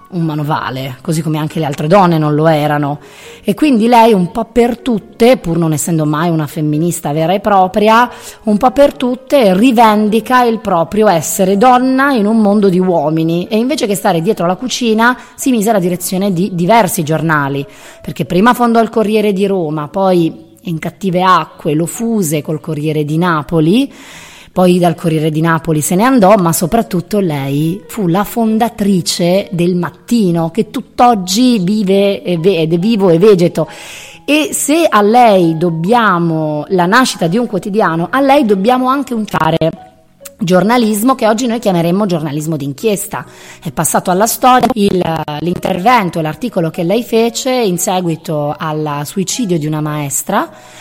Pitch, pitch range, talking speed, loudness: 190 Hz, 165-225 Hz, 160 wpm, -12 LUFS